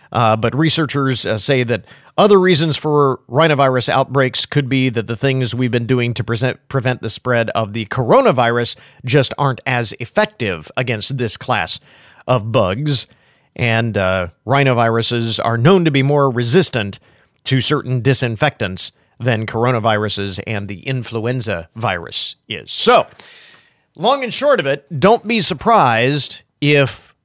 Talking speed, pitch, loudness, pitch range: 145 wpm, 130 Hz, -16 LUFS, 115-140 Hz